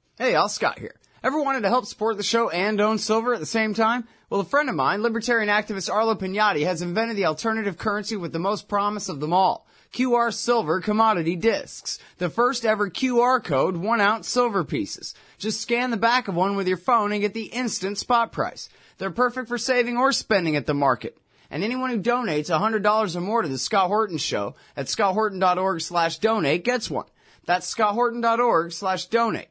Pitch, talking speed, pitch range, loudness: 215 Hz, 200 wpm, 190-235 Hz, -23 LUFS